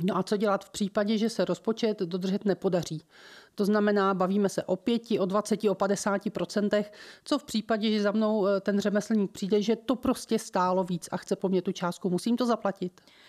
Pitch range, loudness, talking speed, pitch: 190-215 Hz, -28 LUFS, 205 wpm, 205 Hz